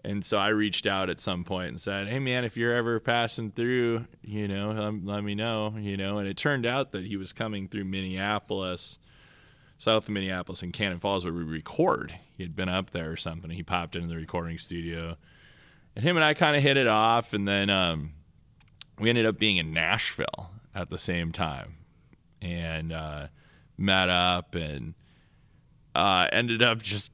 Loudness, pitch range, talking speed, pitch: -27 LUFS, 85-110 Hz, 190 wpm, 100 Hz